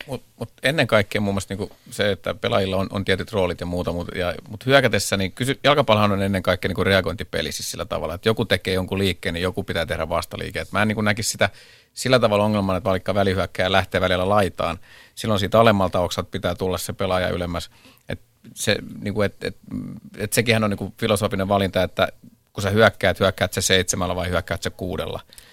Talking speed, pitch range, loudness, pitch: 205 wpm, 90-105 Hz, -22 LUFS, 95 Hz